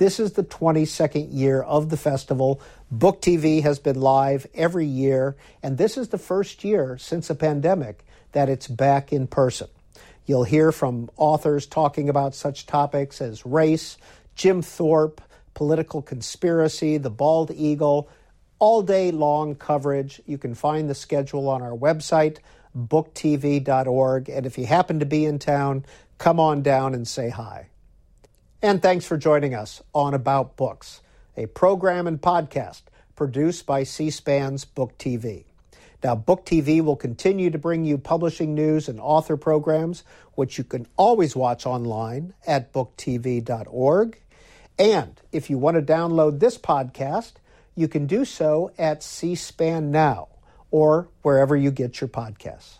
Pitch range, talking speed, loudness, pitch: 135-160 Hz, 150 wpm, -22 LUFS, 145 Hz